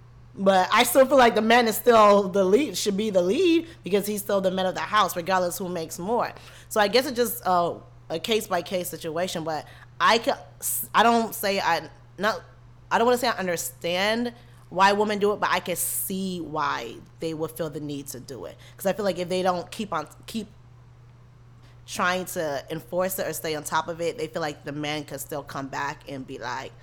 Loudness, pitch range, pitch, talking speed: -24 LUFS, 145-205 Hz, 175 Hz, 230 wpm